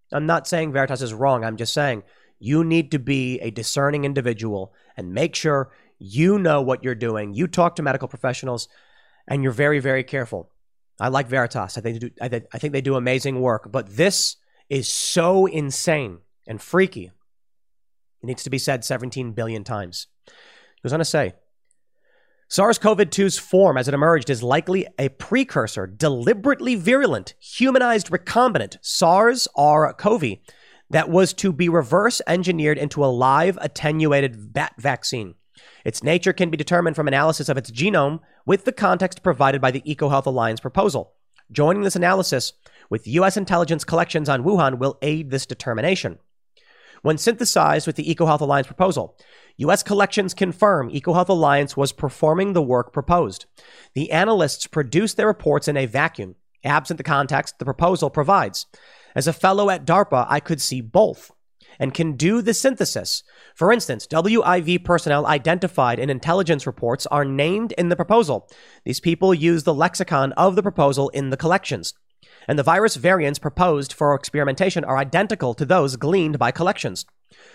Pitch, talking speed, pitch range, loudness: 150 Hz, 165 wpm, 130-180 Hz, -20 LUFS